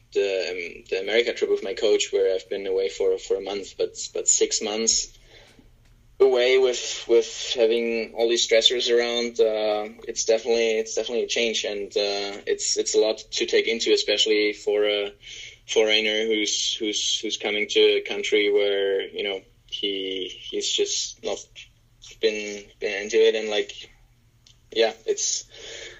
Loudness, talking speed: -23 LUFS, 160 wpm